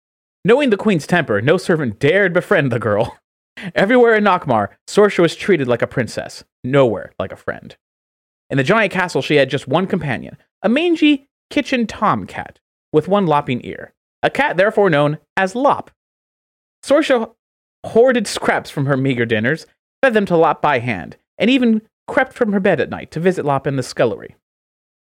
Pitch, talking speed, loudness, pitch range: 190 Hz, 175 wpm, -17 LUFS, 145-225 Hz